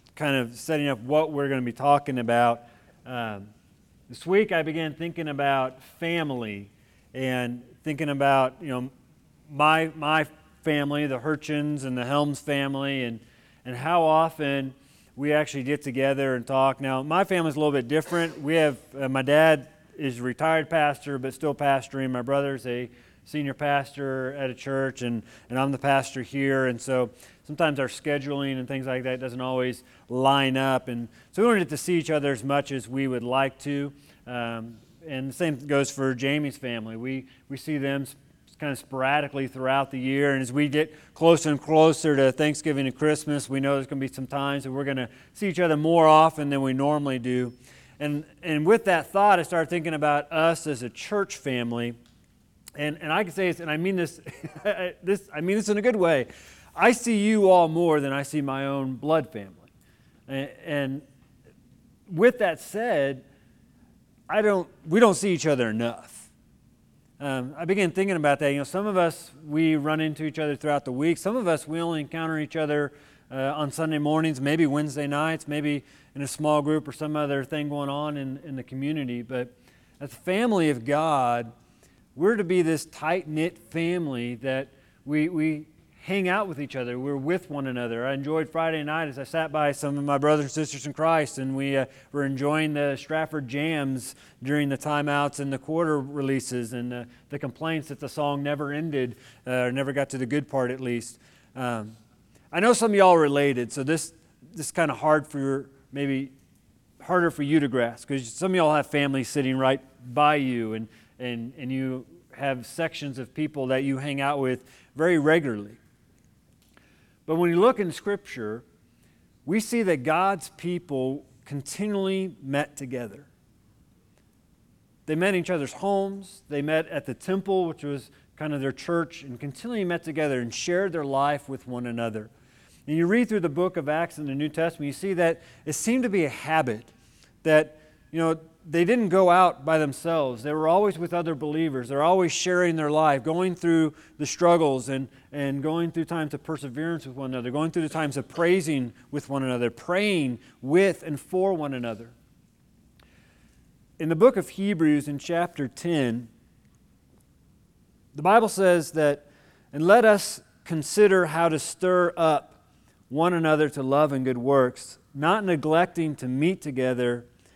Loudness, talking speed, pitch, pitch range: -25 LUFS, 190 wpm, 145 Hz, 130-160 Hz